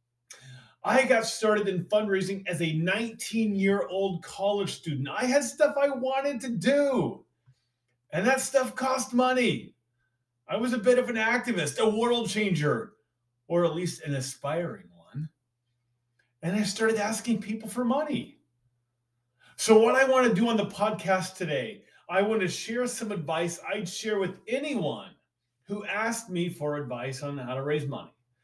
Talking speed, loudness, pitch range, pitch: 160 wpm, -27 LUFS, 140-230 Hz, 195 Hz